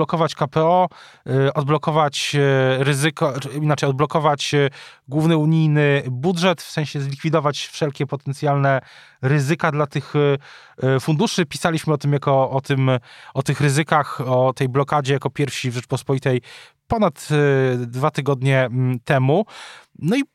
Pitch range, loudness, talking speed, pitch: 135-155 Hz, -20 LUFS, 120 wpm, 145 Hz